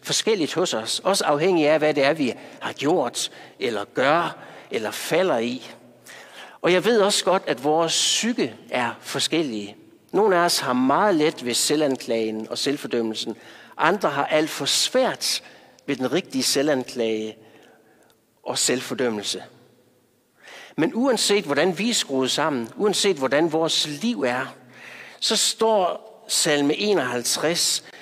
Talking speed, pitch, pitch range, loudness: 135 wpm, 150 Hz, 125-195 Hz, -22 LUFS